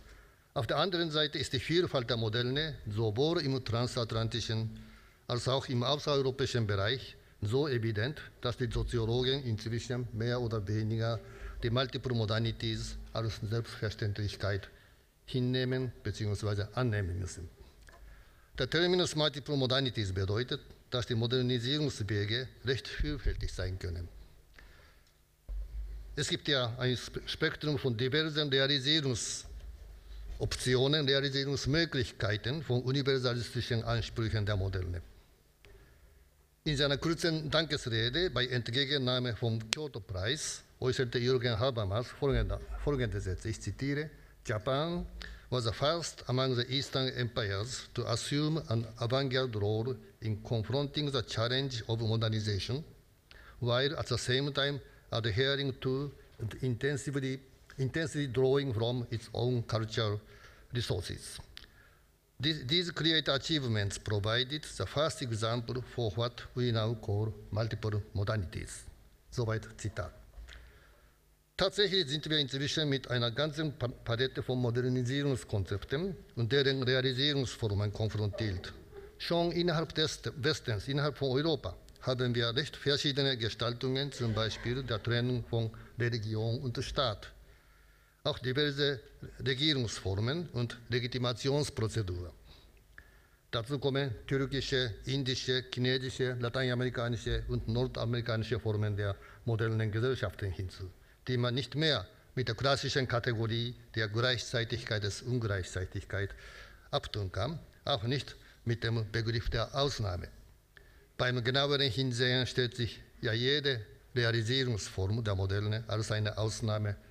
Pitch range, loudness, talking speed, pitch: 110-135 Hz, -33 LUFS, 155 wpm, 120 Hz